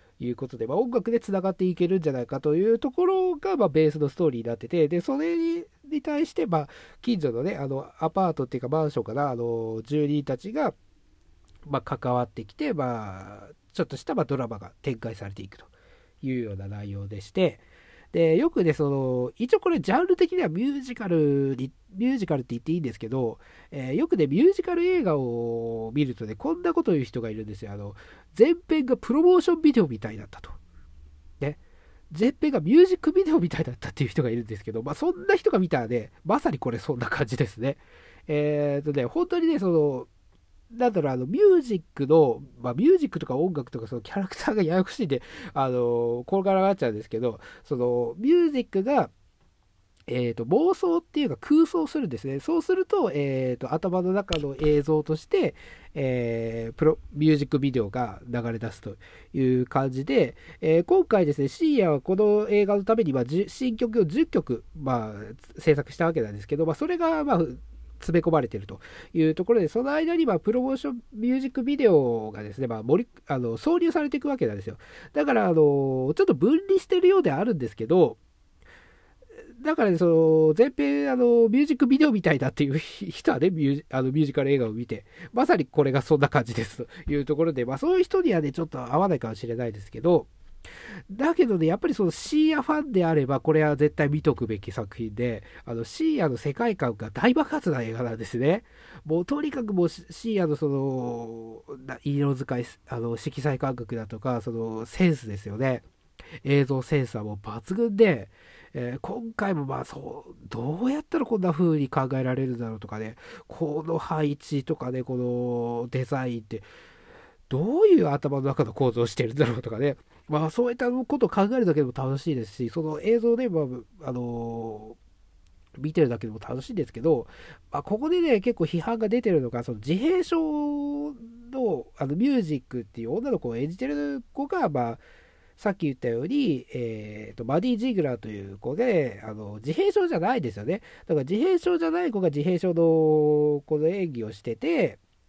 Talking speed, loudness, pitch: 395 characters per minute, -25 LUFS, 150 Hz